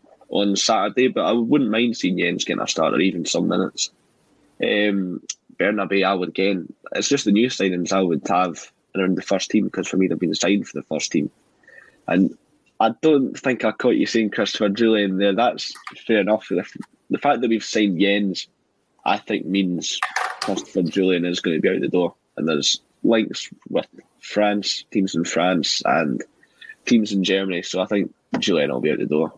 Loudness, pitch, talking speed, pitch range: -21 LUFS, 100 Hz, 190 wpm, 95-105 Hz